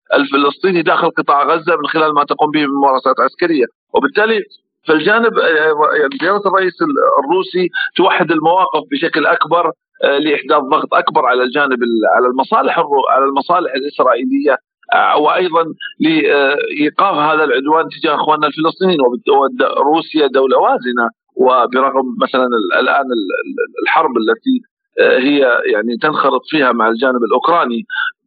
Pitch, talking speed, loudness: 175 Hz, 115 wpm, -13 LUFS